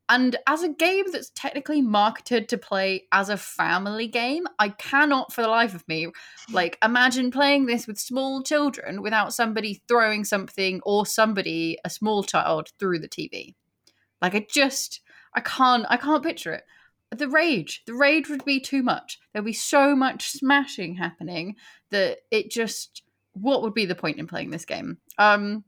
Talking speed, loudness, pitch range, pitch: 175 wpm, -23 LUFS, 205-275 Hz, 230 Hz